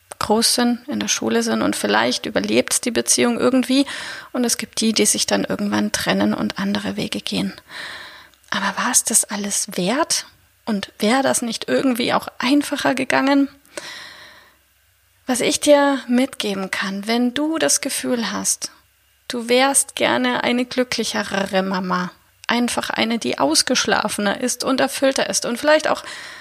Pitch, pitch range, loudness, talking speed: 240 Hz, 195-270 Hz, -19 LUFS, 150 wpm